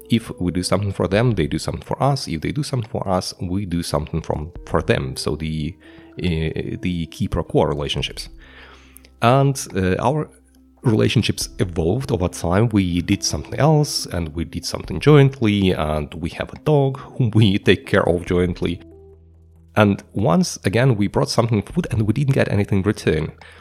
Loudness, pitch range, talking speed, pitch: -20 LUFS, 80-120 Hz, 180 wpm, 95 Hz